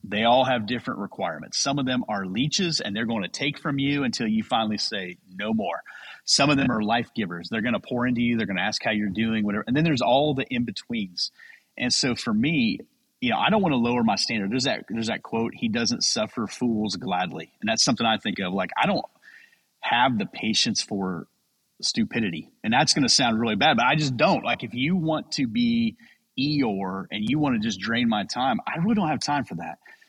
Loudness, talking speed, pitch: -24 LUFS, 235 wpm, 150 Hz